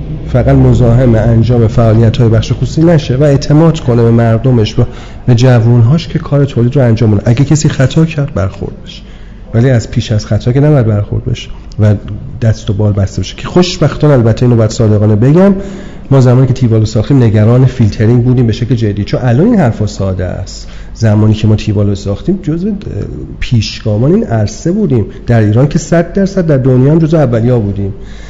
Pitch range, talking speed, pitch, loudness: 110-140 Hz, 185 wpm, 120 Hz, -9 LUFS